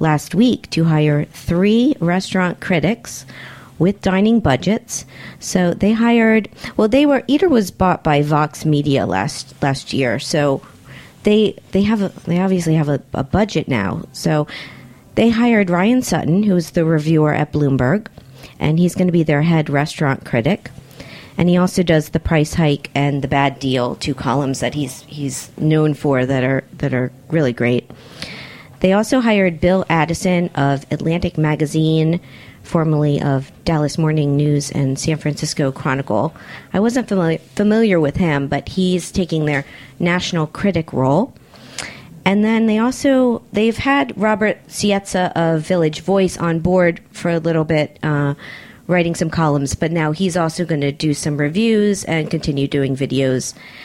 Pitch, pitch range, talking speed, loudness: 160 Hz, 140-185 Hz, 160 wpm, -17 LUFS